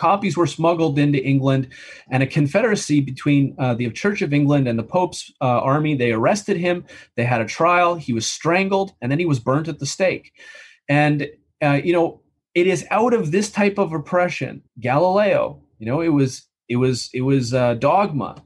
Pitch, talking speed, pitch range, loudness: 145 Hz, 195 wpm, 130-175 Hz, -19 LUFS